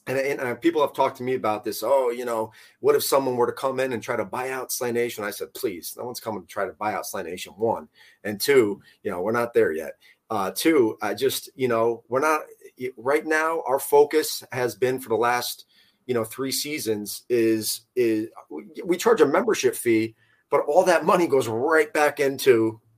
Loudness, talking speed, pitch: -24 LUFS, 220 wpm, 140 Hz